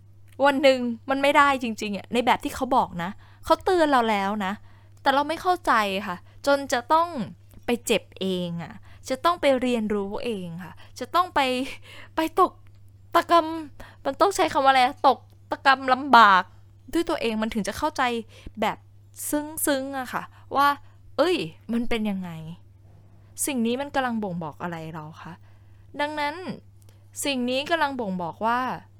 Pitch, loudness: 235 Hz, -24 LUFS